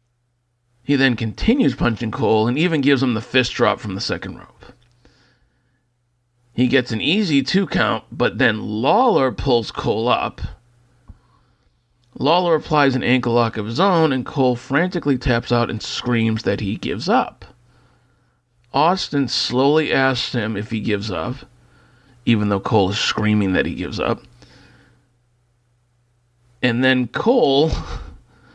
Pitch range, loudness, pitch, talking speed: 120-130 Hz, -19 LUFS, 120 Hz, 140 wpm